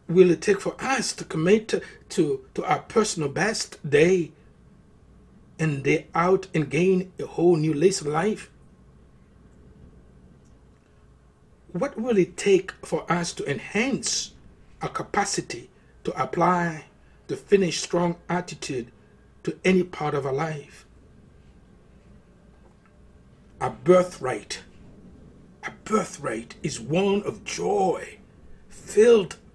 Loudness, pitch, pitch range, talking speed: -24 LUFS, 175 Hz, 145-190 Hz, 110 wpm